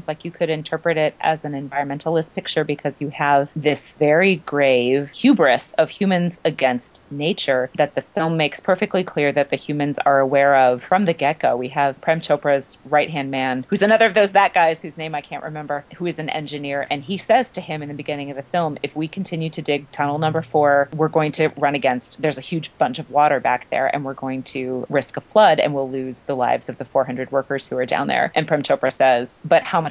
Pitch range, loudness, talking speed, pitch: 140-165 Hz, -20 LUFS, 235 wpm, 150 Hz